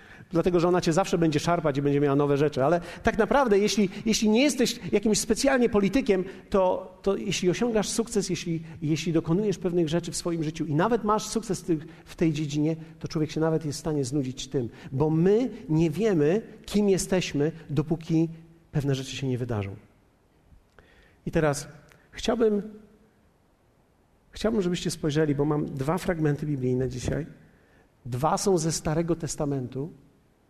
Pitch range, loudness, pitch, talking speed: 150-195 Hz, -26 LUFS, 165 Hz, 155 wpm